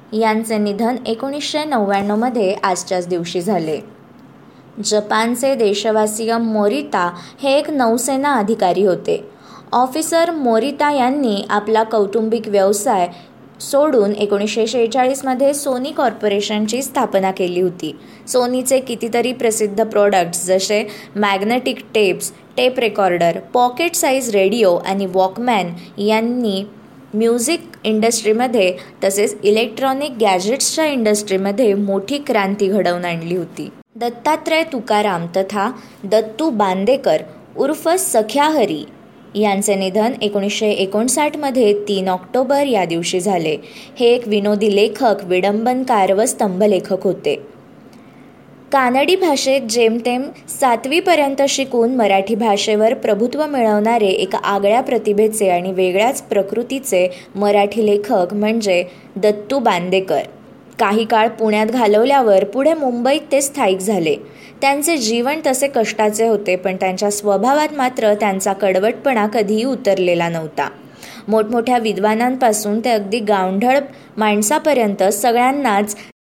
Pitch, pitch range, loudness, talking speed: 220 Hz, 200-255 Hz, -16 LUFS, 100 wpm